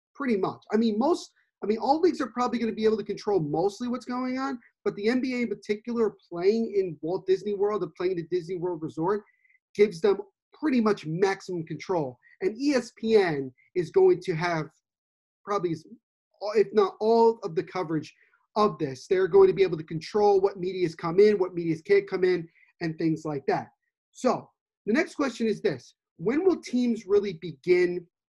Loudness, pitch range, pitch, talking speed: -27 LUFS, 175-245 Hz, 205 Hz, 190 wpm